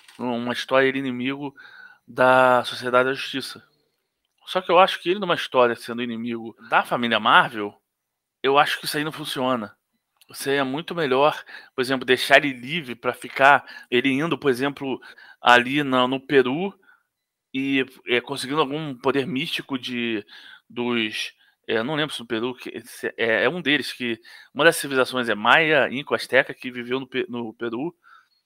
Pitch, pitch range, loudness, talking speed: 130 Hz, 120-140 Hz, -22 LUFS, 165 wpm